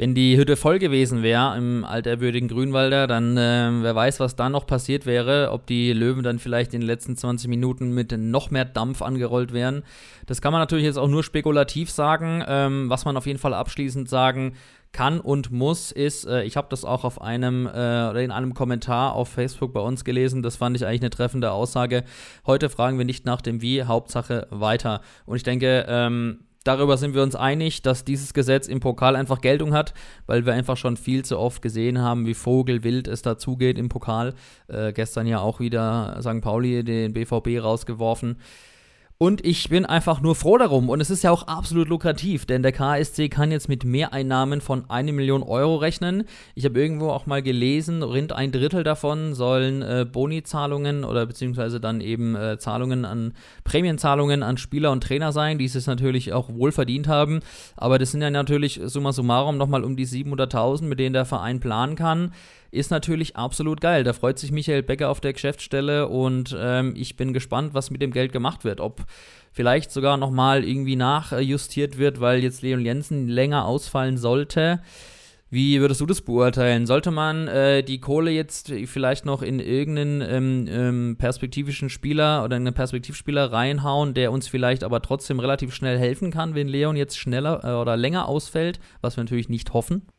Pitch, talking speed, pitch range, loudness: 130 Hz, 190 wpm, 125-145 Hz, -23 LUFS